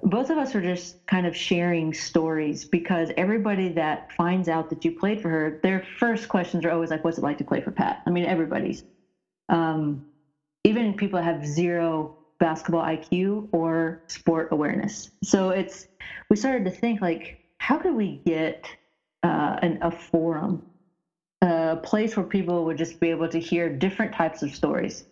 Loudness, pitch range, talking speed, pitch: -25 LUFS, 165-190 Hz, 175 wpm, 170 Hz